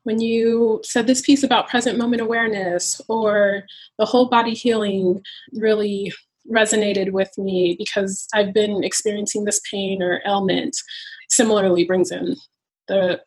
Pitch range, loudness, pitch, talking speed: 195-230 Hz, -19 LUFS, 210 Hz, 135 wpm